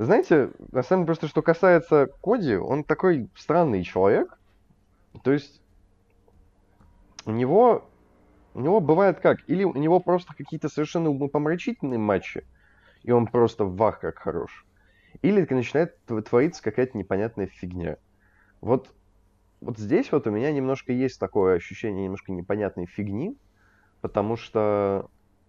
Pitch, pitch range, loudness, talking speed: 110 Hz, 95-150 Hz, -24 LUFS, 130 wpm